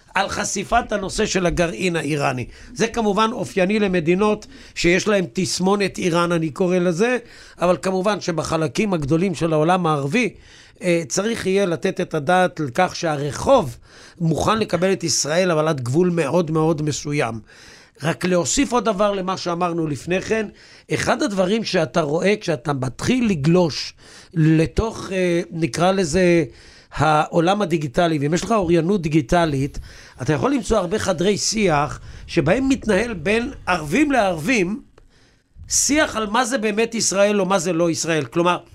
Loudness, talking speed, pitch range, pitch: -20 LUFS, 140 wpm, 160-200 Hz, 180 Hz